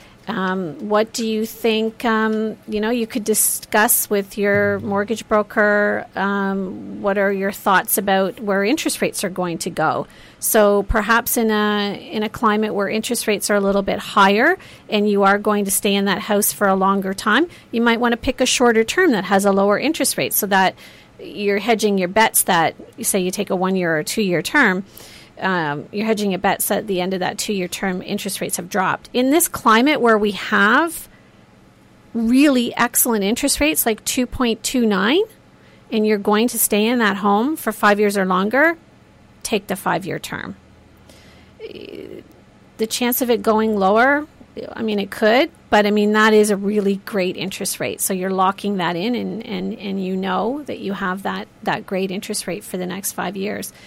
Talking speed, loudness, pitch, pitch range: 195 wpm, -18 LUFS, 210 Hz, 195-230 Hz